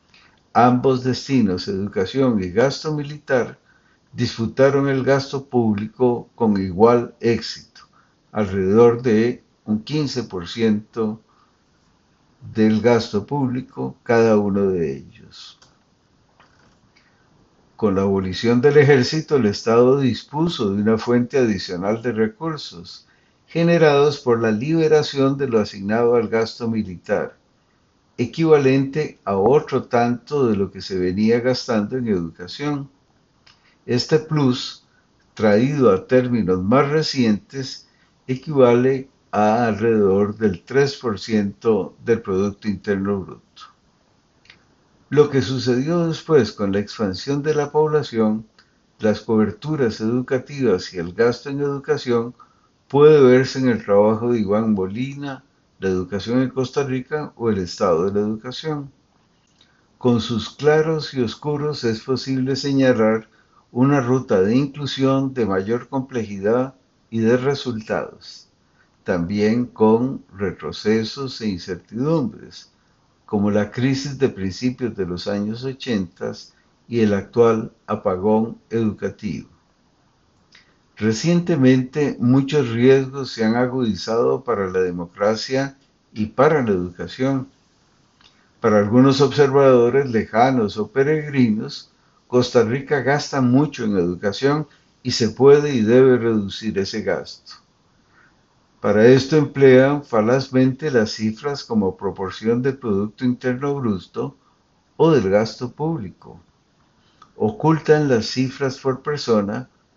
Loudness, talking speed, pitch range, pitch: -19 LUFS, 110 wpm, 110-135 Hz, 120 Hz